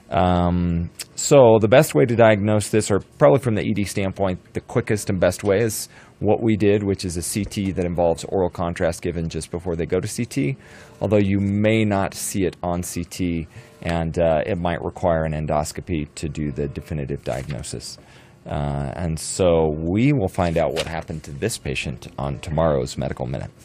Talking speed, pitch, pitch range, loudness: 190 wpm, 90 Hz, 80-105 Hz, -21 LUFS